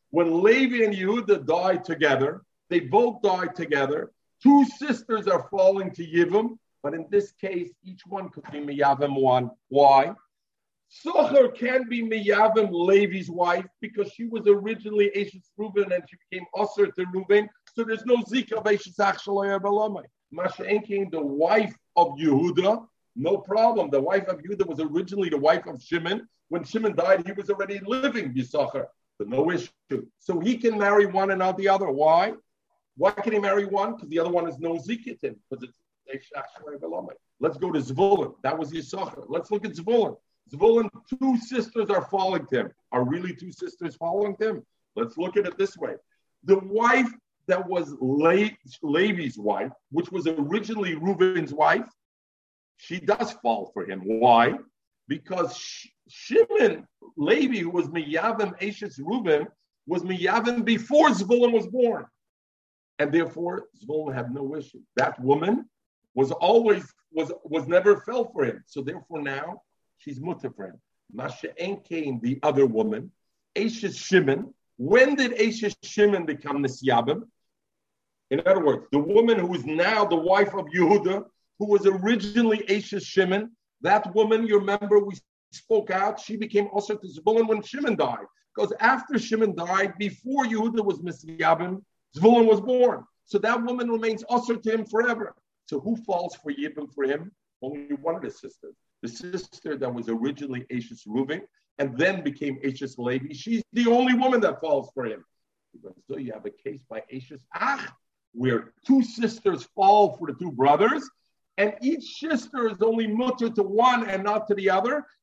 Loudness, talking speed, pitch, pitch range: -24 LUFS, 160 wpm, 200 Hz, 165-225 Hz